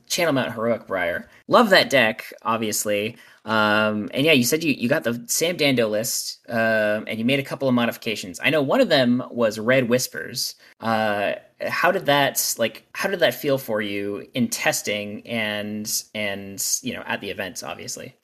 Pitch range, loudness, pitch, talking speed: 105-120 Hz, -22 LUFS, 110 Hz, 190 wpm